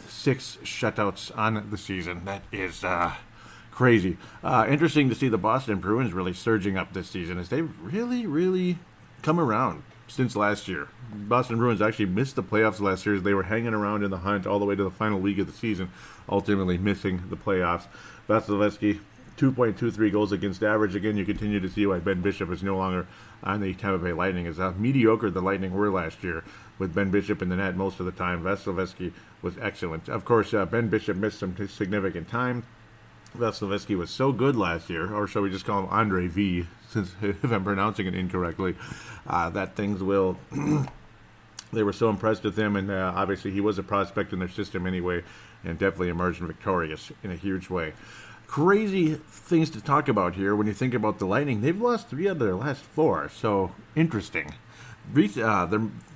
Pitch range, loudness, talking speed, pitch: 95-110 Hz, -27 LUFS, 200 wpm, 105 Hz